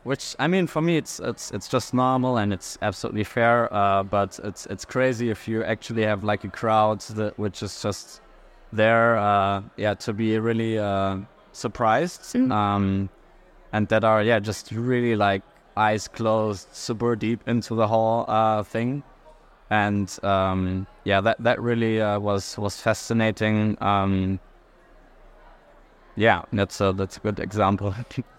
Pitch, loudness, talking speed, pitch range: 110 Hz, -24 LUFS, 155 wpm, 100-115 Hz